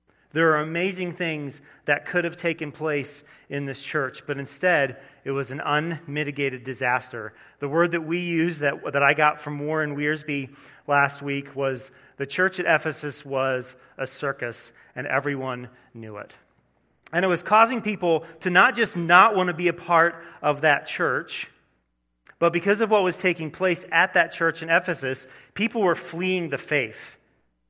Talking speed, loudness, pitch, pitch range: 170 wpm, -23 LUFS, 150 Hz, 140-170 Hz